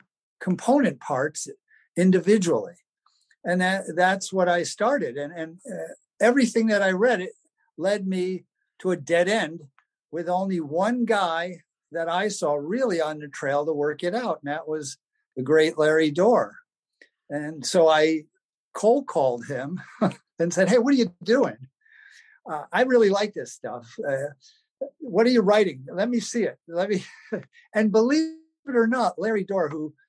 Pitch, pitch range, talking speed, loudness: 185 Hz, 160-235 Hz, 165 wpm, -24 LUFS